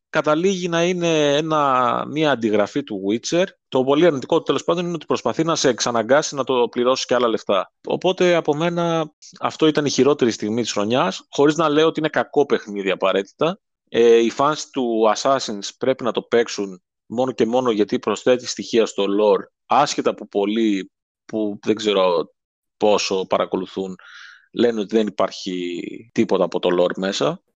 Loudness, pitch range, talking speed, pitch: -20 LUFS, 105-155 Hz, 170 wpm, 130 Hz